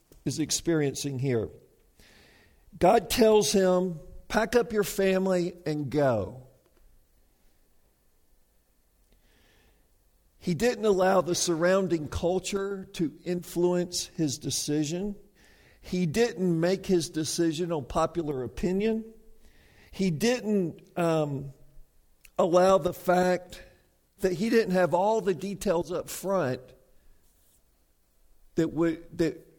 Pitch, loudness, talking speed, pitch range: 175 Hz, -27 LUFS, 95 wpm, 140-190 Hz